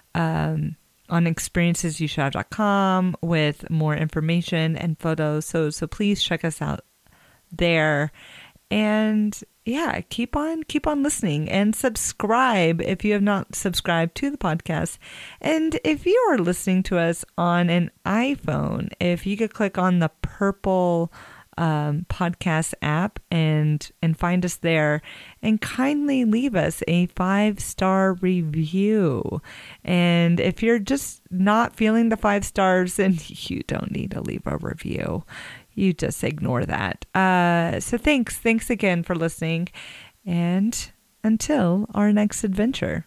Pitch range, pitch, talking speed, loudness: 165-215 Hz, 185 Hz, 135 wpm, -23 LUFS